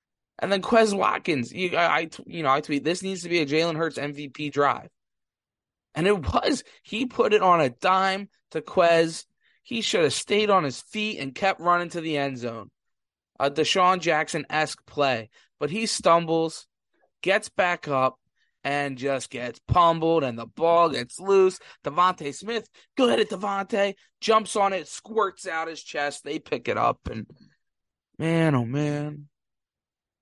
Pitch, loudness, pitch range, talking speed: 165 Hz, -24 LUFS, 145-190 Hz, 165 wpm